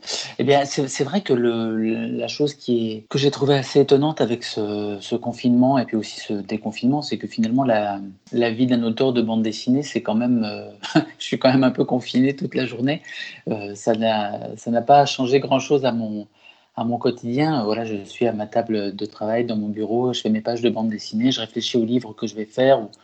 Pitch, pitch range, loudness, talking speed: 120 Hz, 110-130 Hz, -21 LUFS, 235 wpm